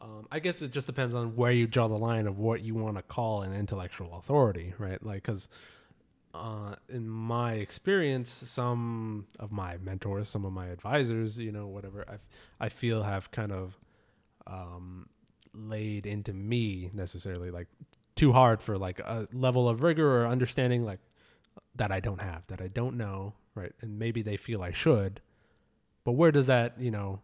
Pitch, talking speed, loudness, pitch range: 110 Hz, 185 wpm, -31 LUFS, 100-120 Hz